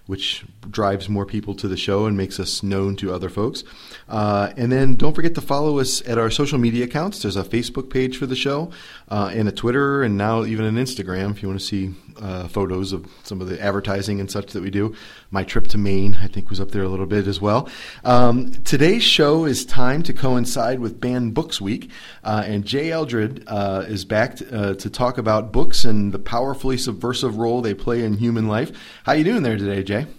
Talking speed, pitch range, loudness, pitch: 225 wpm, 100-125 Hz, -21 LUFS, 110 Hz